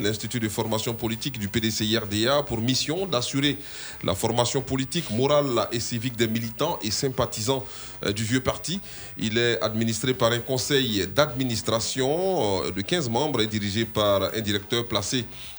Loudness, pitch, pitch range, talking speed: -25 LUFS, 120 Hz, 110-135 Hz, 145 wpm